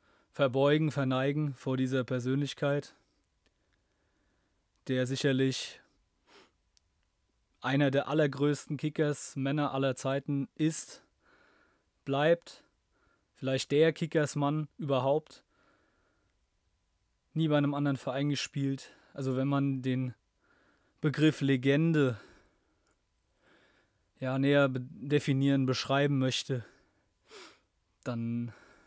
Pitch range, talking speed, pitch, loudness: 125-145 Hz, 80 wpm, 135 Hz, -31 LUFS